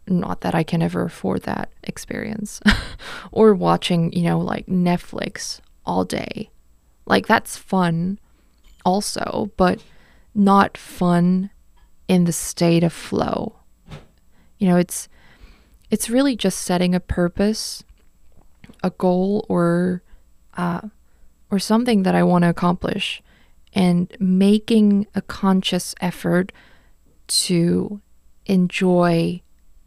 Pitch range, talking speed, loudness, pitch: 175-200 Hz, 110 wpm, -20 LUFS, 180 Hz